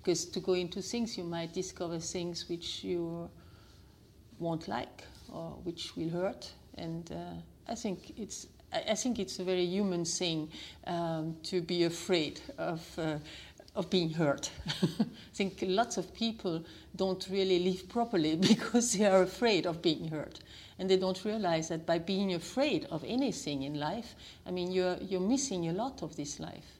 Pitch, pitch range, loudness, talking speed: 180 Hz, 165-190 Hz, -34 LUFS, 170 wpm